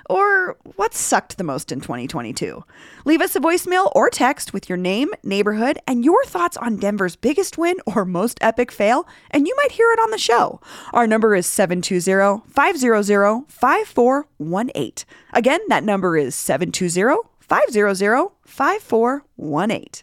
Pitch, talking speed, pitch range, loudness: 240 Hz, 145 wpm, 200-340 Hz, -19 LUFS